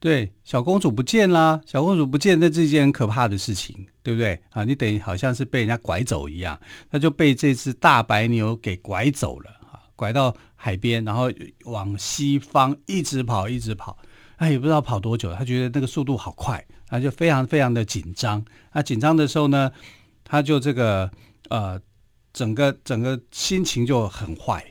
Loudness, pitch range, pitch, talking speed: -22 LUFS, 110-145 Hz, 125 Hz, 275 characters per minute